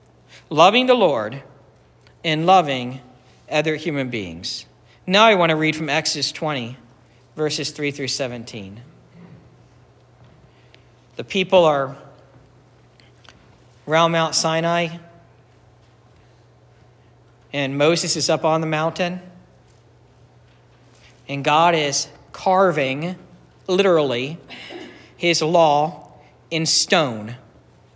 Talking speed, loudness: 90 wpm, -19 LUFS